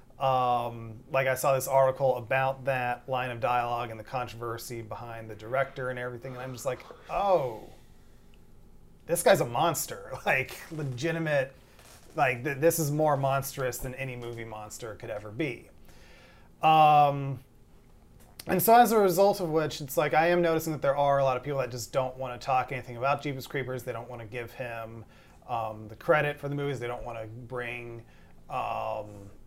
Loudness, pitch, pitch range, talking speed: -28 LUFS, 130 Hz, 120-140 Hz, 185 wpm